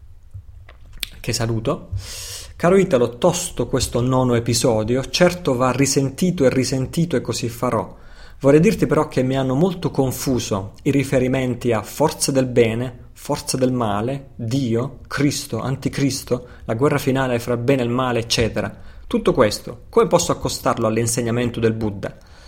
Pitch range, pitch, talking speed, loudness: 115-140 Hz, 125 Hz, 145 wpm, -20 LUFS